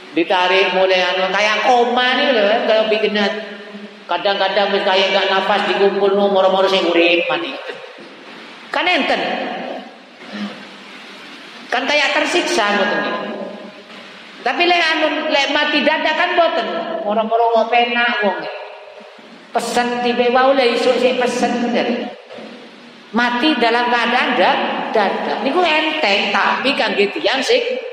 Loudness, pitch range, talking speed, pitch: -15 LUFS, 200-280 Hz, 135 wpm, 240 Hz